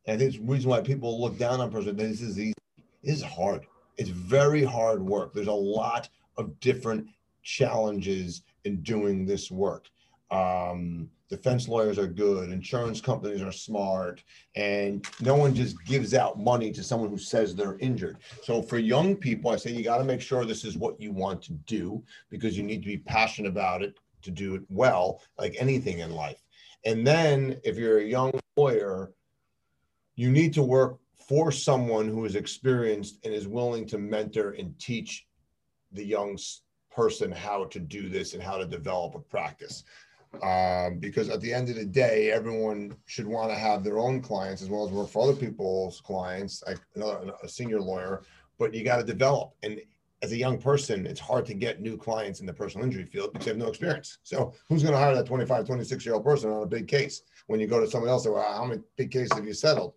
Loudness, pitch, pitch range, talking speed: -28 LUFS, 110 Hz, 100-130 Hz, 205 wpm